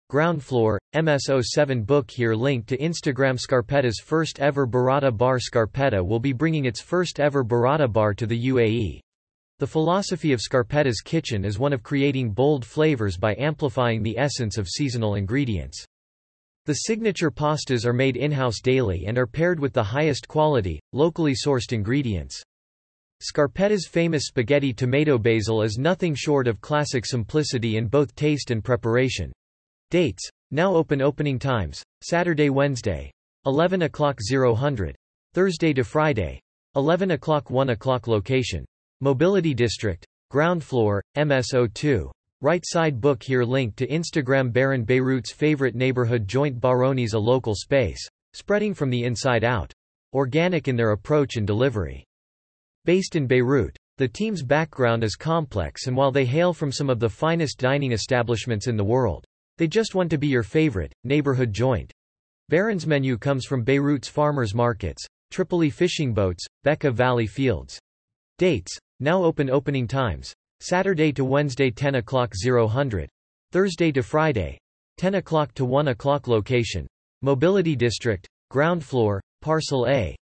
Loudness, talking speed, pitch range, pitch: -23 LUFS, 145 wpm, 115-150 Hz, 130 Hz